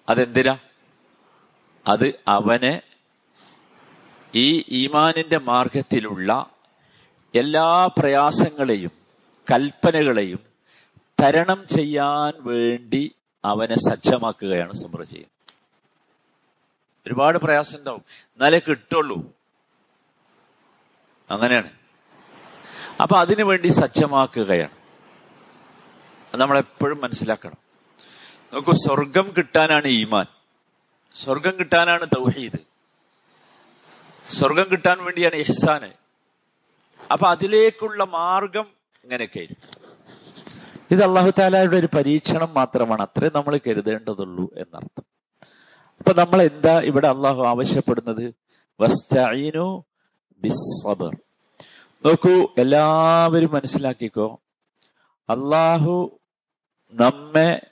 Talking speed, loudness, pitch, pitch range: 60 wpm, -19 LUFS, 150 Hz, 125-170 Hz